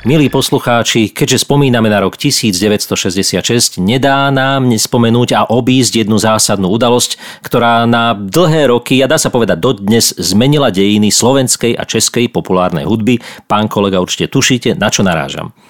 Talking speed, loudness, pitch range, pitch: 150 wpm, -11 LUFS, 105-130 Hz, 120 Hz